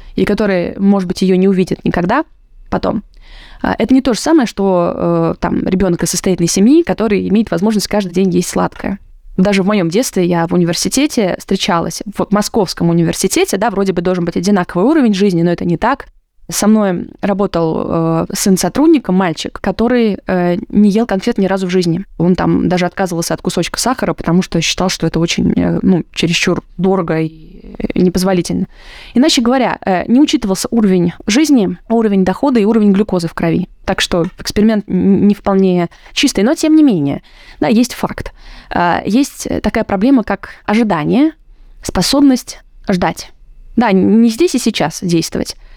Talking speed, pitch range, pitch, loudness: 170 wpm, 175-225 Hz, 195 Hz, -13 LUFS